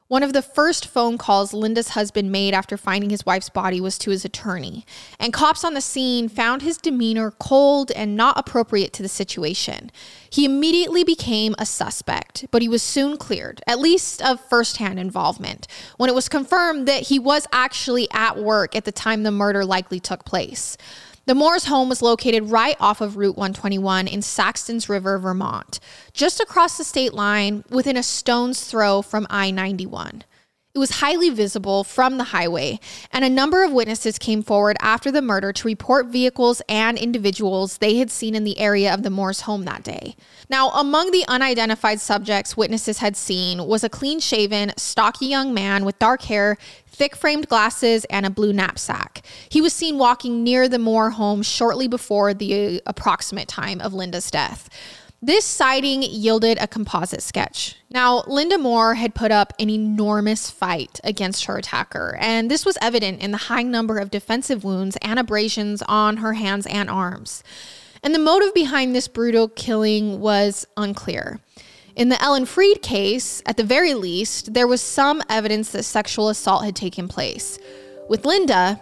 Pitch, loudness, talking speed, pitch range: 225 Hz, -20 LUFS, 175 wpm, 205-260 Hz